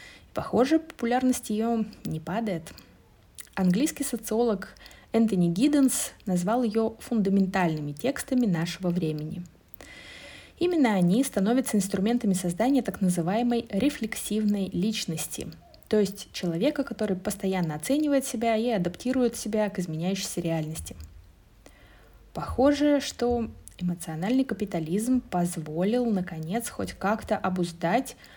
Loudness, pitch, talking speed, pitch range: -27 LUFS, 210 Hz, 95 wpm, 175-240 Hz